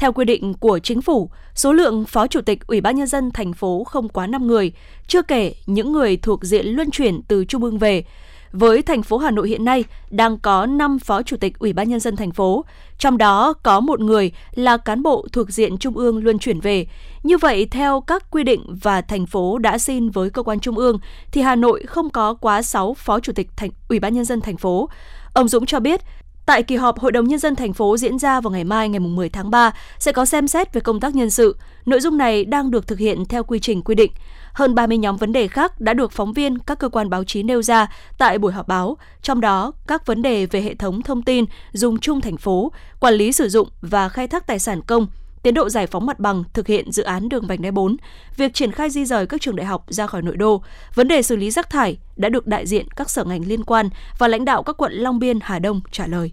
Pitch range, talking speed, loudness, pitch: 205-255 Hz, 255 wpm, -18 LUFS, 230 Hz